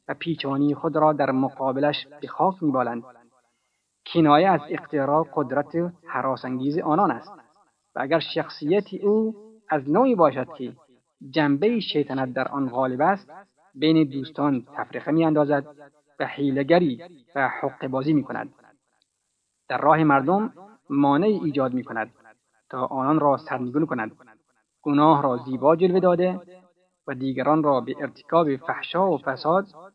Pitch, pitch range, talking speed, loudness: 145 Hz, 130-165 Hz, 130 wpm, -23 LUFS